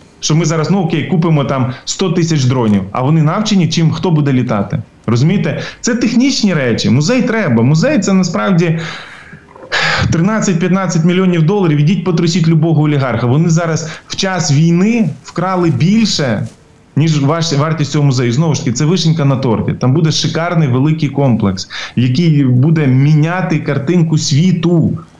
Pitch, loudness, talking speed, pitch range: 160 Hz, -12 LUFS, 145 wpm, 140-180 Hz